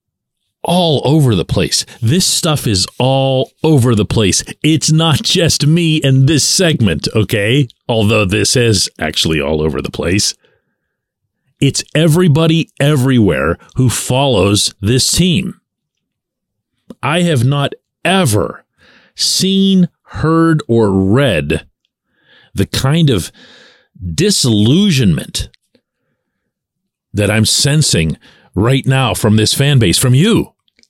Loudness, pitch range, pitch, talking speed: -12 LUFS, 110-155 Hz, 135 Hz, 110 wpm